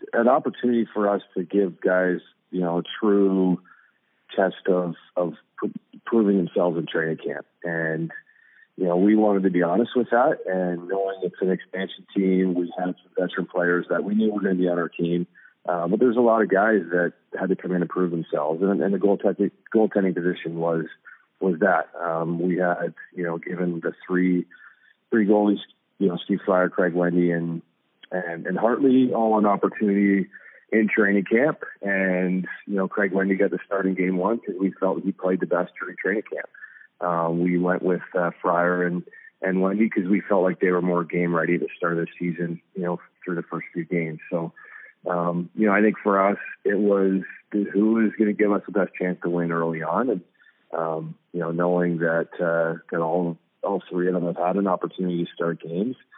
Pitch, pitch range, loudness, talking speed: 90 Hz, 85-100 Hz, -24 LUFS, 205 wpm